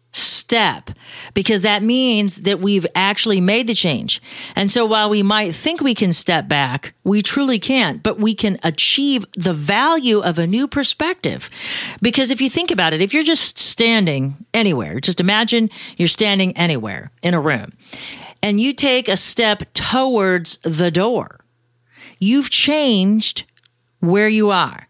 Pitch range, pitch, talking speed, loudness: 175-235 Hz, 205 Hz, 155 wpm, -16 LUFS